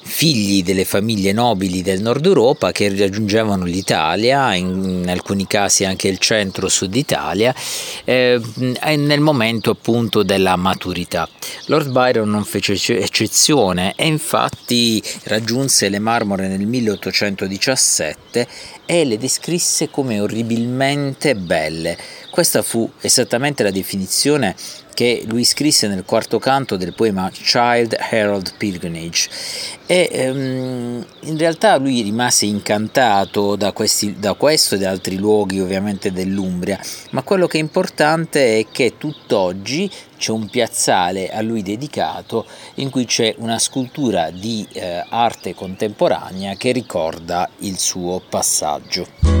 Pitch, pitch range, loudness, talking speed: 110 Hz, 95-125 Hz, -17 LUFS, 120 wpm